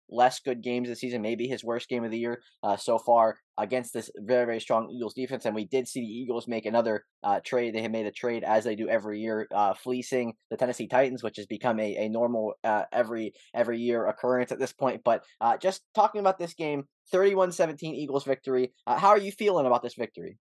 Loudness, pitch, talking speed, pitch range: -28 LUFS, 120 Hz, 230 wpm, 115-130 Hz